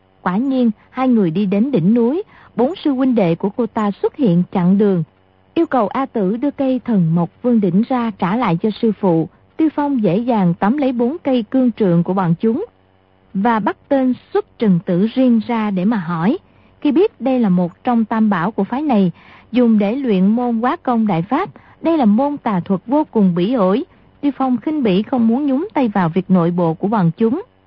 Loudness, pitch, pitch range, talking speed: -17 LUFS, 225 Hz, 190-255 Hz, 220 wpm